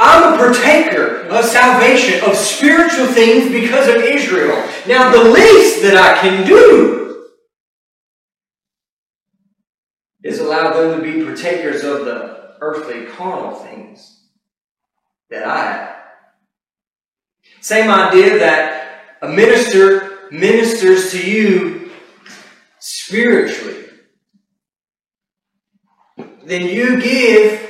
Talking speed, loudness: 95 wpm, -10 LUFS